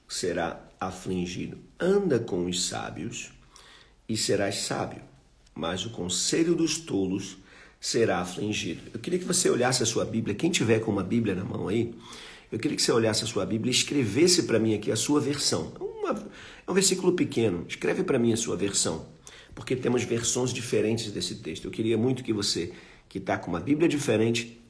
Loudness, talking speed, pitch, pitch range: -27 LUFS, 180 wpm, 115 Hz, 100-130 Hz